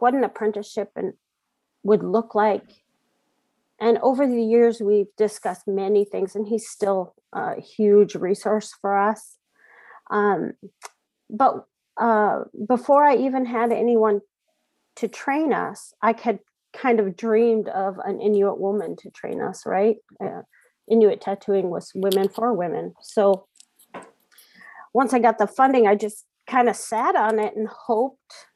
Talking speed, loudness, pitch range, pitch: 145 wpm, -22 LUFS, 205-235 Hz, 215 Hz